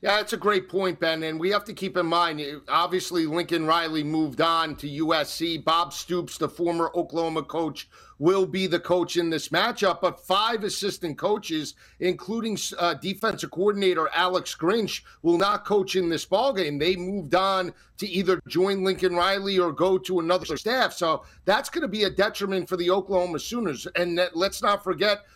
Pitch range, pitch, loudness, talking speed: 170-195 Hz, 180 Hz, -25 LUFS, 185 wpm